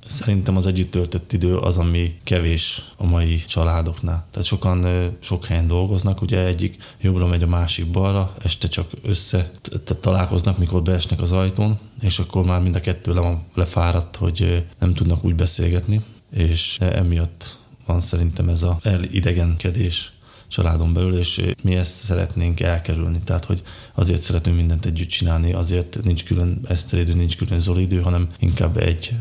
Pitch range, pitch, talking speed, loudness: 85-95 Hz, 90 Hz, 160 wpm, -21 LUFS